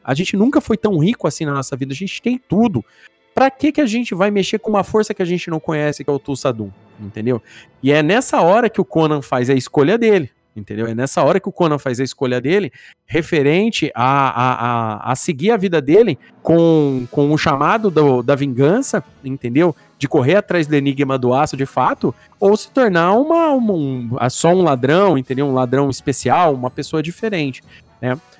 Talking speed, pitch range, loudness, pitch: 210 wpm, 135-200 Hz, -16 LUFS, 150 Hz